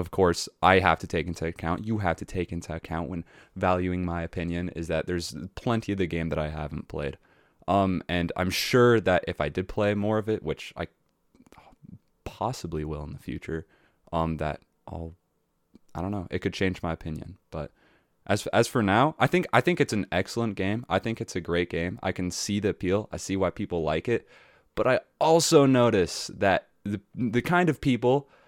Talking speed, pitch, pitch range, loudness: 210 wpm, 90 Hz, 85-105 Hz, -27 LUFS